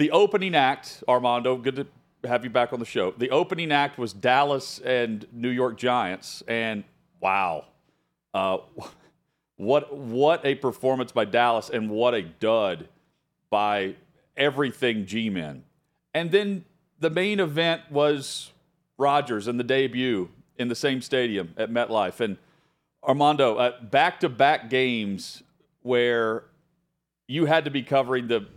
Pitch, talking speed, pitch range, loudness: 130 Hz, 135 wpm, 120-150 Hz, -25 LUFS